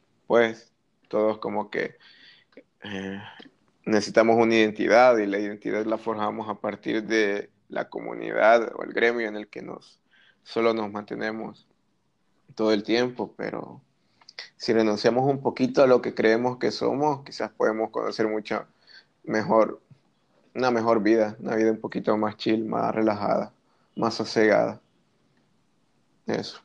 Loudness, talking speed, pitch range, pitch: -24 LUFS, 135 wpm, 105-115 Hz, 110 Hz